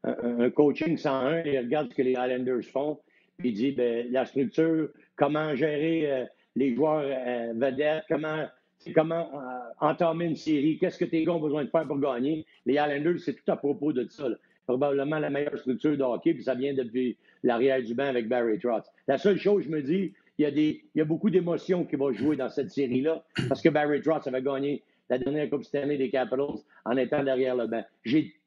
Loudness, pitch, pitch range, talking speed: -28 LUFS, 145 Hz, 130-160 Hz, 215 wpm